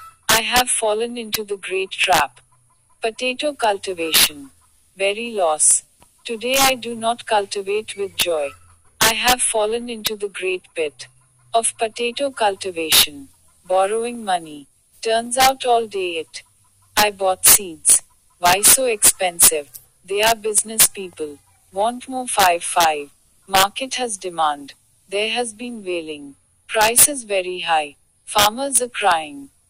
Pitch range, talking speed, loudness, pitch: 160-235 Hz, 130 wpm, -17 LUFS, 205 Hz